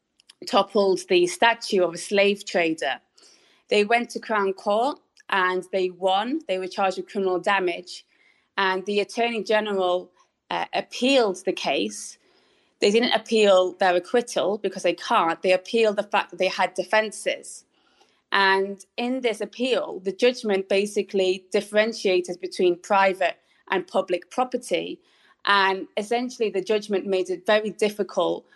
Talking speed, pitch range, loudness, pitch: 140 wpm, 185-220 Hz, -23 LUFS, 200 Hz